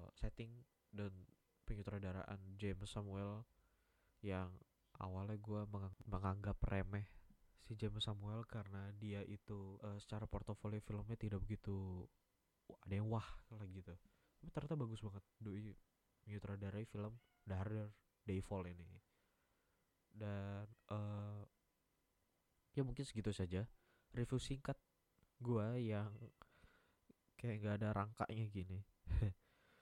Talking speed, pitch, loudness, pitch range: 105 wpm, 105 Hz, -48 LUFS, 95-110 Hz